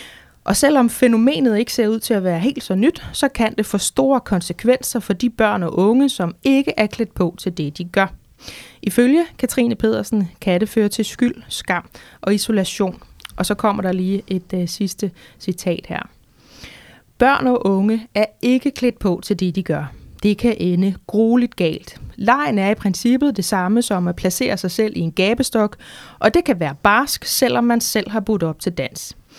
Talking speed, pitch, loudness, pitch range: 195 wpm, 215 Hz, -18 LUFS, 185-240 Hz